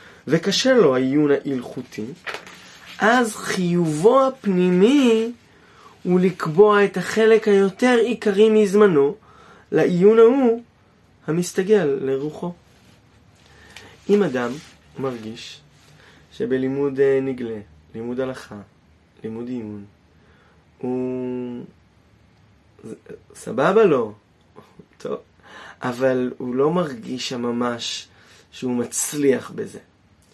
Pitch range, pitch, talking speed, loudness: 120-195 Hz, 135 Hz, 75 wpm, -19 LUFS